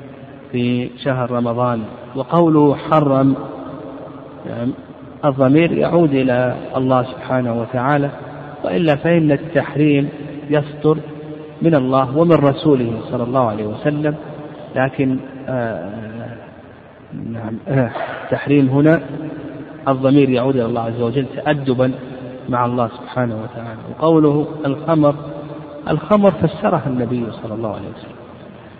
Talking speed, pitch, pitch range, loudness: 100 wpm, 140 Hz, 125-150 Hz, -17 LUFS